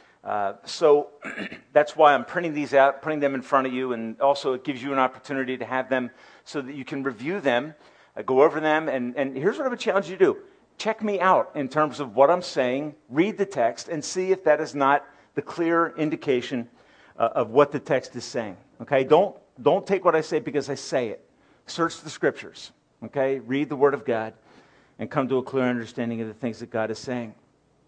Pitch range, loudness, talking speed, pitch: 130-155 Hz, -24 LUFS, 225 wpm, 140 Hz